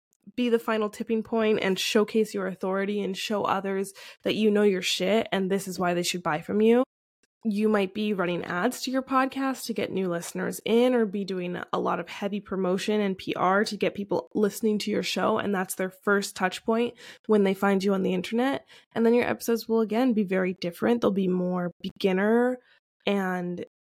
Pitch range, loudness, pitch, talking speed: 185-225 Hz, -26 LUFS, 205 Hz, 210 wpm